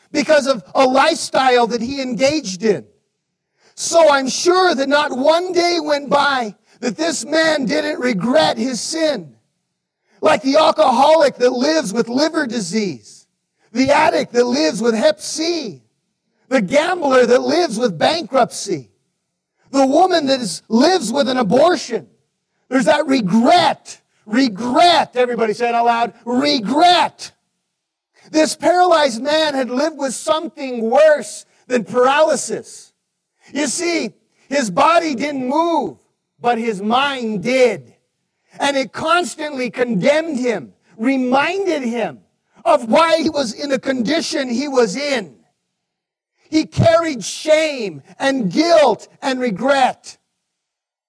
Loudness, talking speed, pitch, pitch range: -16 LUFS, 125 wpm, 270 Hz, 235-310 Hz